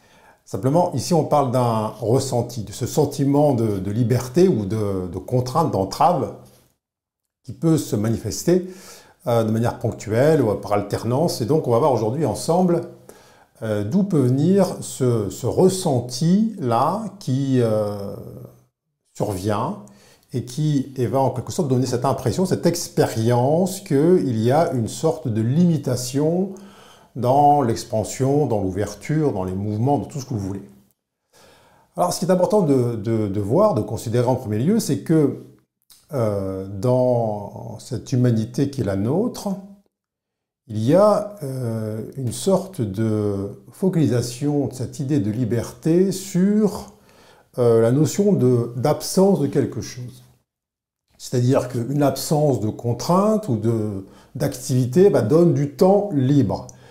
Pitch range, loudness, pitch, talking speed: 110-160 Hz, -20 LUFS, 130 Hz, 140 wpm